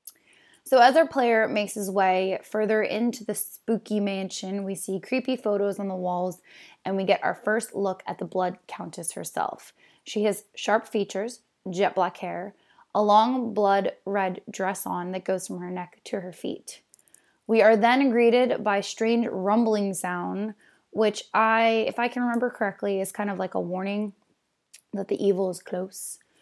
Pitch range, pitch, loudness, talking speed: 190-225 Hz, 205 Hz, -25 LUFS, 175 wpm